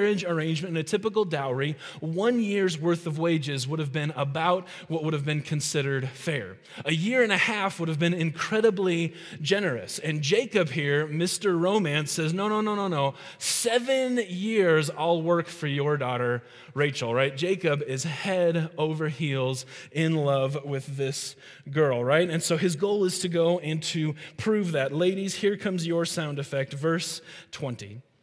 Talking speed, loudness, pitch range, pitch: 170 wpm, -26 LUFS, 145-185 Hz, 165 Hz